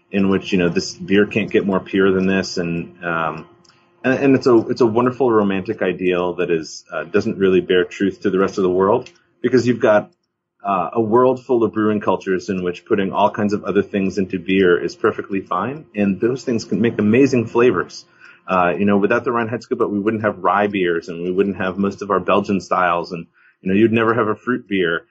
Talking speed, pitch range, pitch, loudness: 230 wpm, 95-115 Hz, 100 Hz, -18 LUFS